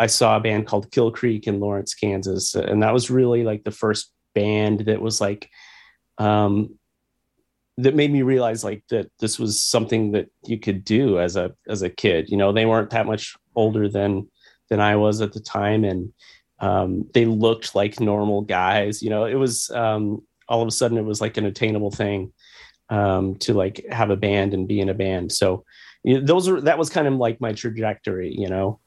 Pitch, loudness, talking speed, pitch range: 110 Hz, -21 LUFS, 210 wpm, 100-115 Hz